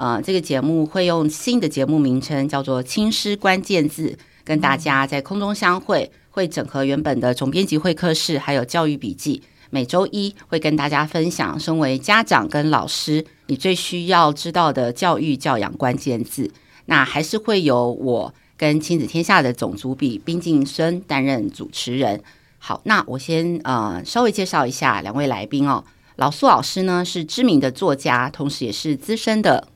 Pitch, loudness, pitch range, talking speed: 155 Hz, -20 LUFS, 135-175 Hz, 270 characters per minute